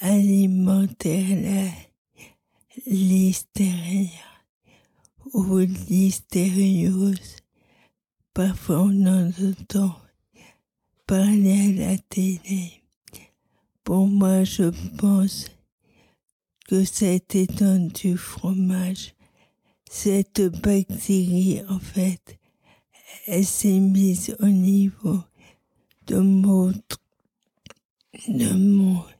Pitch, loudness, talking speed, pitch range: 190 Hz, -21 LUFS, 70 wpm, 185-195 Hz